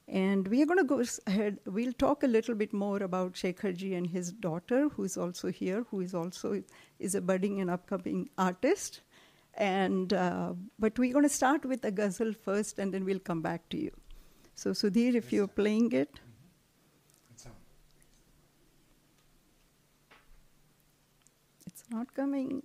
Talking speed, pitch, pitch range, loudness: 155 wpm, 195 Hz, 180-230 Hz, -32 LUFS